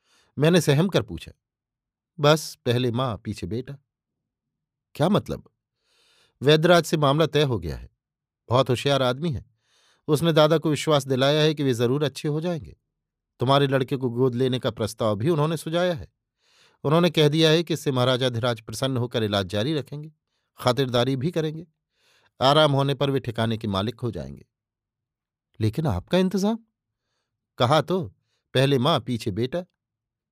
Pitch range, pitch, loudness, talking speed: 120-155 Hz, 135 Hz, -23 LUFS, 155 wpm